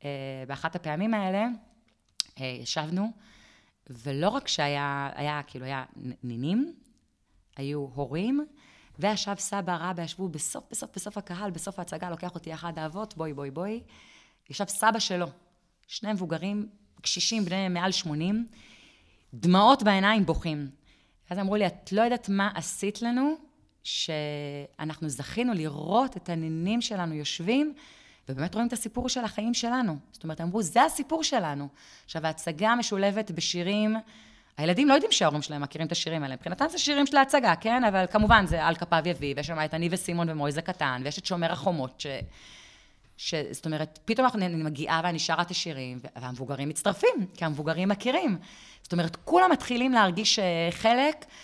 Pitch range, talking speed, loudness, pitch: 155-220 Hz, 155 wpm, -28 LUFS, 180 Hz